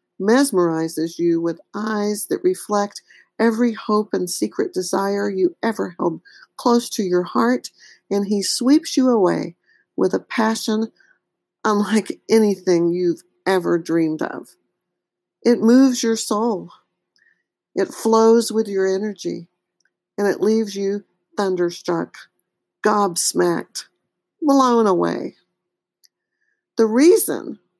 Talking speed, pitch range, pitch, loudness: 110 wpm, 185-230 Hz, 210 Hz, -19 LUFS